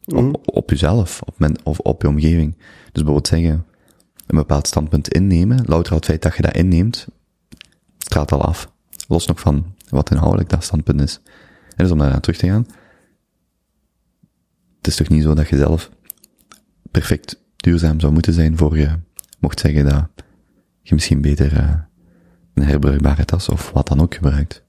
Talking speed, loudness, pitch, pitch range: 175 wpm, -17 LUFS, 80 Hz, 75-85 Hz